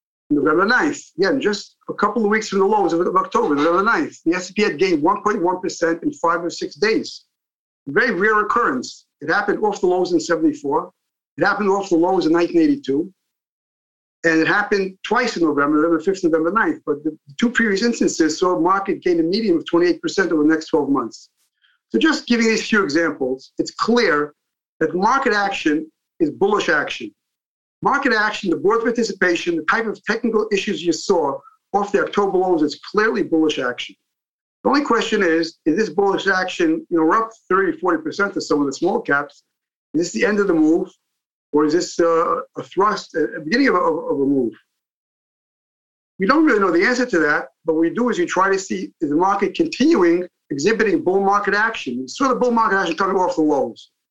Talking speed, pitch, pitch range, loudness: 195 wpm, 195 Hz, 165-245 Hz, -19 LUFS